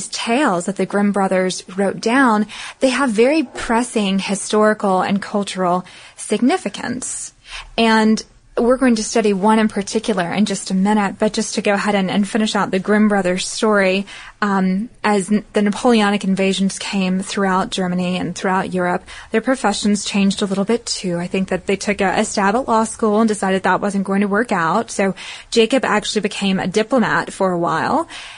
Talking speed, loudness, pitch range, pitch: 180 wpm, -18 LUFS, 195-220 Hz, 205 Hz